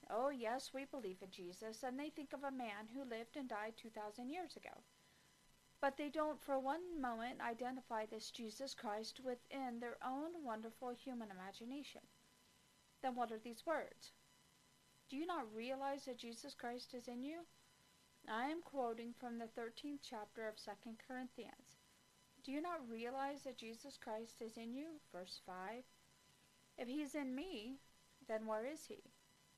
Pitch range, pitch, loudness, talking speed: 225-275 Hz, 250 Hz, -48 LUFS, 165 wpm